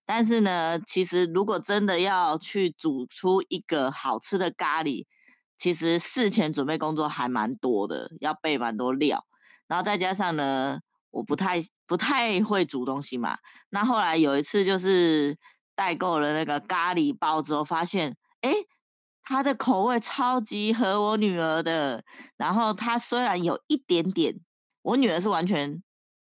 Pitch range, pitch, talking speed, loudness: 155-215 Hz, 180 Hz, 230 characters per minute, -26 LUFS